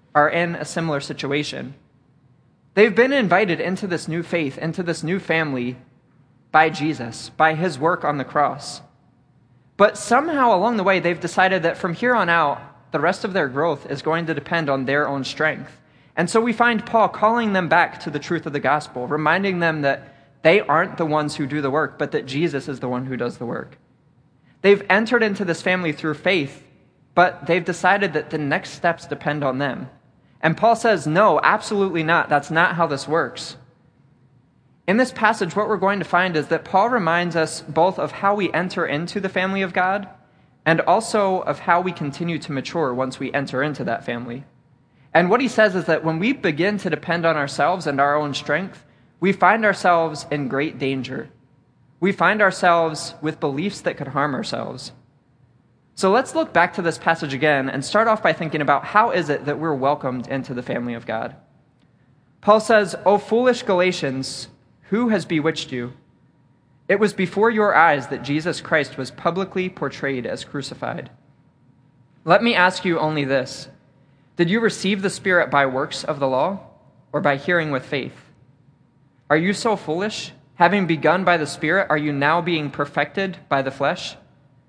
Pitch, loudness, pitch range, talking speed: 155 Hz, -20 LUFS, 140-185 Hz, 190 wpm